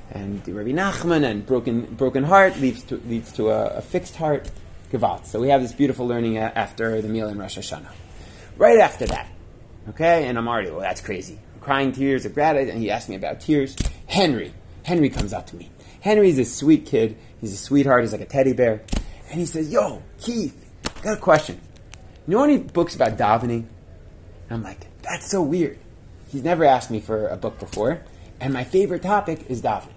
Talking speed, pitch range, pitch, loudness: 205 wpm, 105-145 Hz, 120 Hz, -21 LUFS